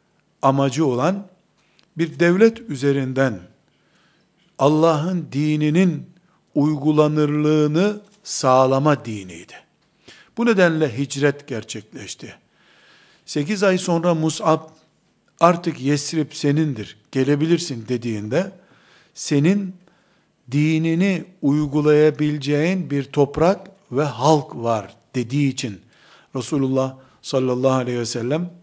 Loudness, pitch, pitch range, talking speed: -20 LUFS, 150 Hz, 135-170 Hz, 80 wpm